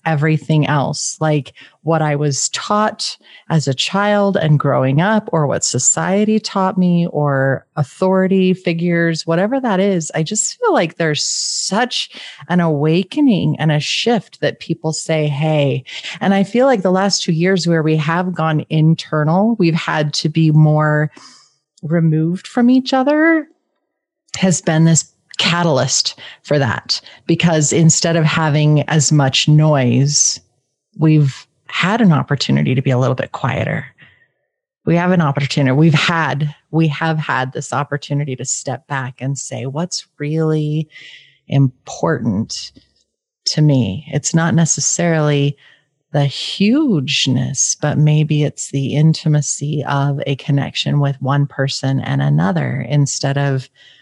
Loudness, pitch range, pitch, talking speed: -16 LUFS, 145-175 Hz, 155 Hz, 140 wpm